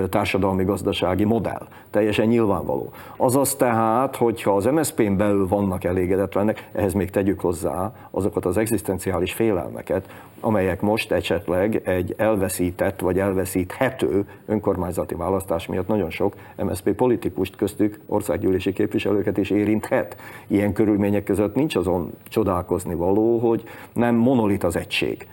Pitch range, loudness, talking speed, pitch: 95-110 Hz, -22 LUFS, 125 wpm, 100 Hz